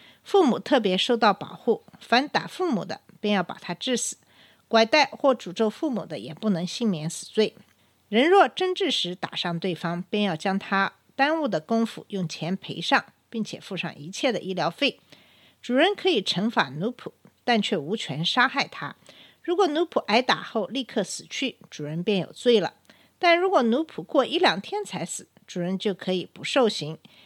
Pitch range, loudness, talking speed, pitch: 180-265 Hz, -25 LUFS, 260 characters per minute, 215 Hz